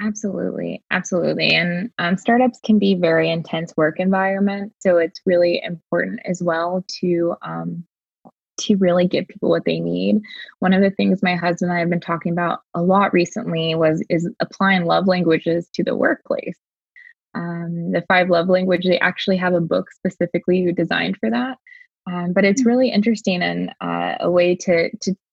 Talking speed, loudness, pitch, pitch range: 180 wpm, -19 LUFS, 180 Hz, 170-195 Hz